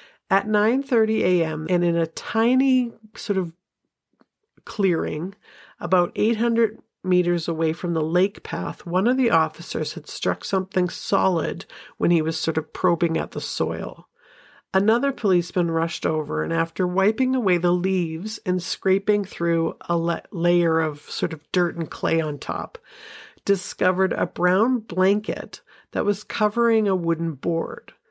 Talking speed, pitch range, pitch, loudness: 145 wpm, 165-210 Hz, 180 Hz, -23 LUFS